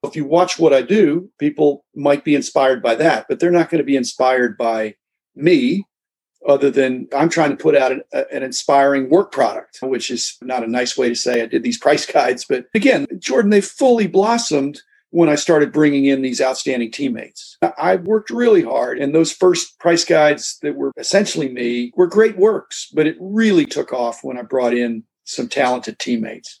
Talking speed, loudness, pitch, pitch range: 200 wpm, -17 LUFS, 145 Hz, 130-180 Hz